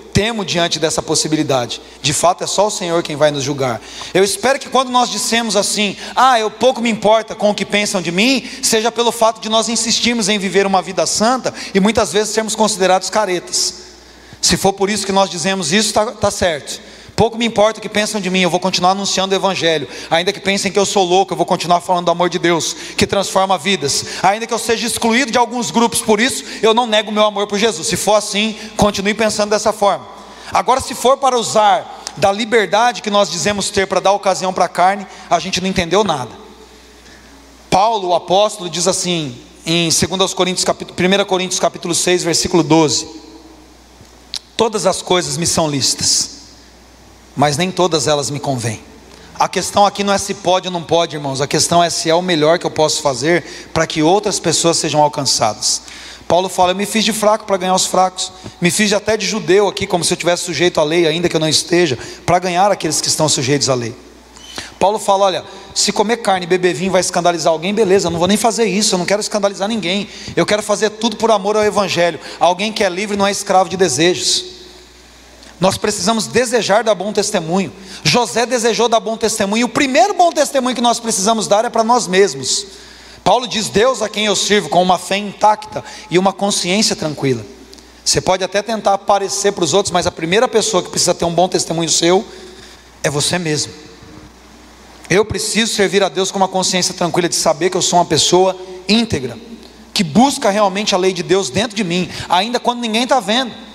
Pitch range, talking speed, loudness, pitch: 175-215 Hz, 210 wpm, -15 LUFS, 195 Hz